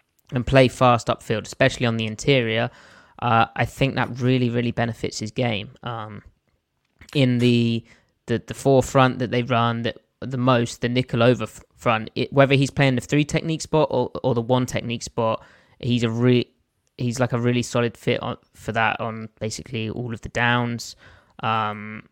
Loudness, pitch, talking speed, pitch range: -22 LUFS, 120 Hz, 180 wpm, 115-125 Hz